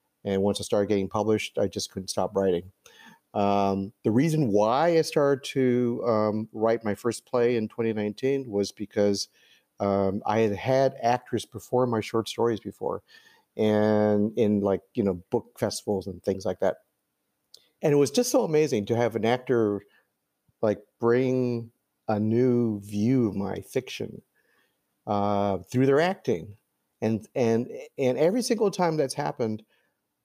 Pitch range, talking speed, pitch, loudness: 100-125 Hz, 155 wpm, 110 Hz, -26 LUFS